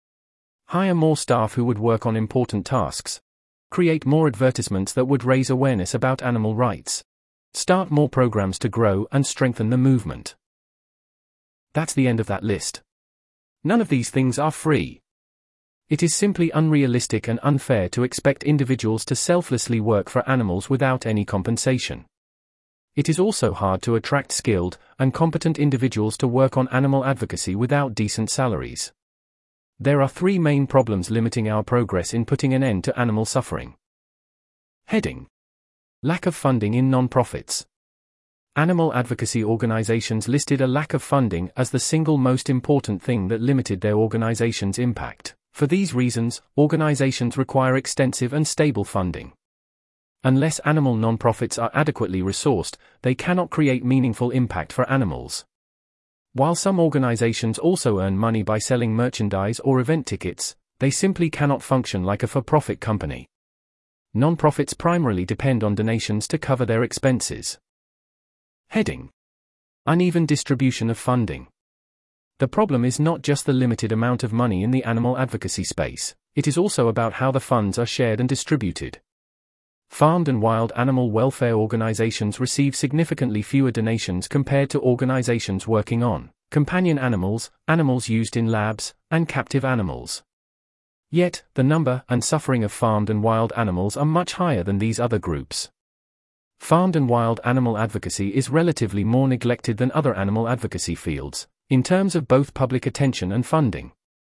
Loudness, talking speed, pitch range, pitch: -22 LUFS, 150 wpm, 110-140 Hz, 125 Hz